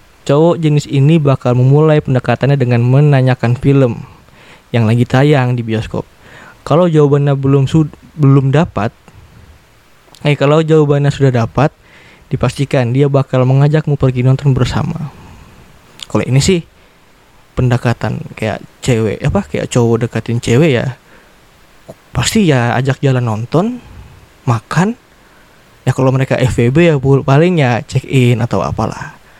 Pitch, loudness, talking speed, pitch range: 135 Hz, -12 LUFS, 120 wpm, 120-145 Hz